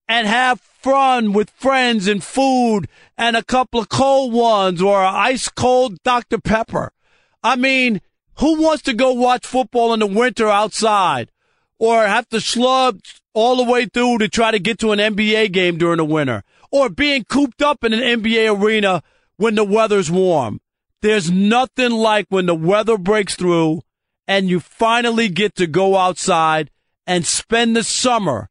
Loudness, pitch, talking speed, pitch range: -16 LUFS, 225 Hz, 170 wpm, 195-250 Hz